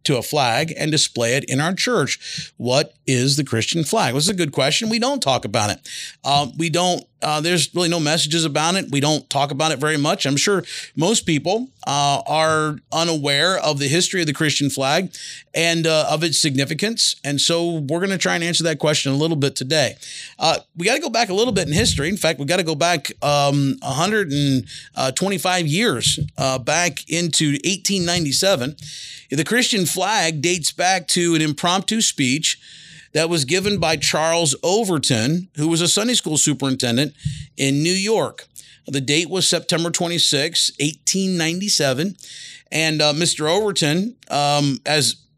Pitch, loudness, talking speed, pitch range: 160 Hz, -19 LUFS, 180 wpm, 145-175 Hz